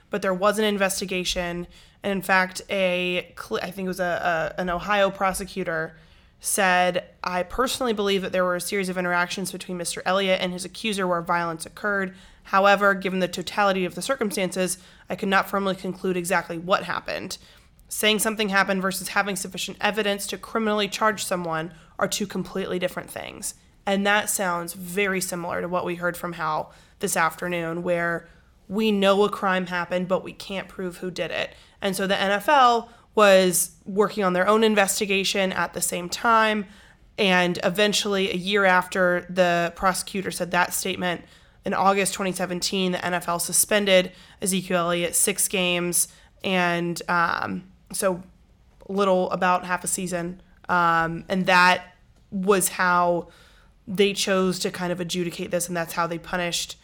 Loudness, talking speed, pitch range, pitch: -23 LUFS, 165 wpm, 175-200 Hz, 185 Hz